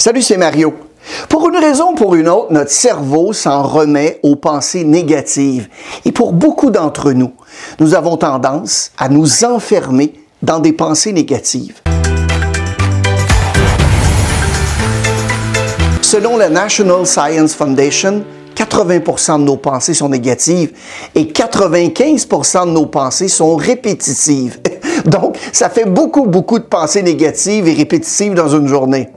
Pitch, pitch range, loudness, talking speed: 155 Hz, 130-195 Hz, -11 LUFS, 130 wpm